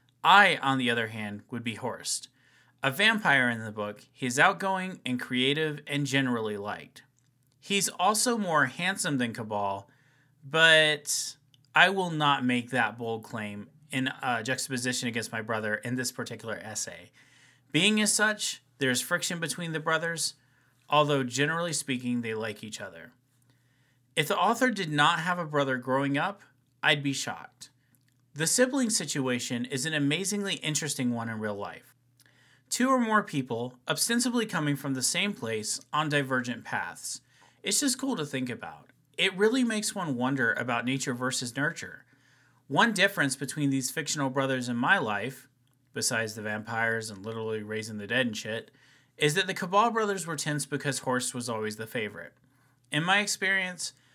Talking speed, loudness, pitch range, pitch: 160 wpm, -28 LUFS, 125-160 Hz, 135 Hz